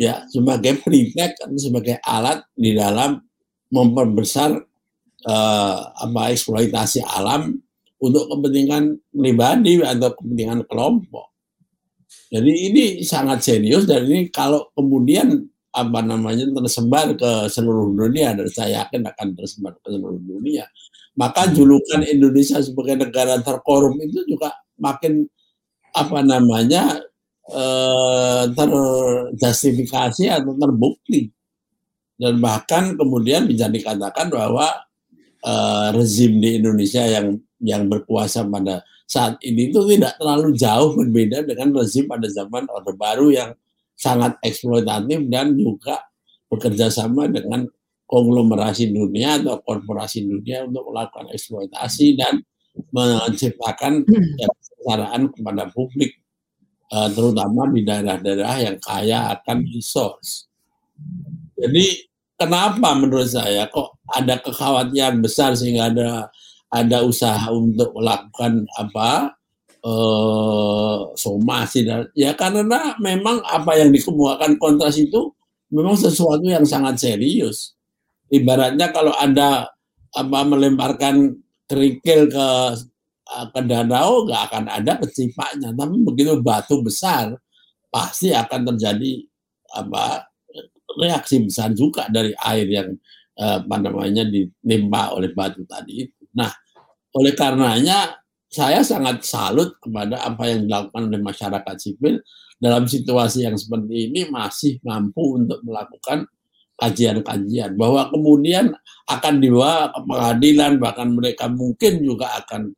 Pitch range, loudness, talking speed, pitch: 115-150 Hz, -18 LUFS, 110 wpm, 125 Hz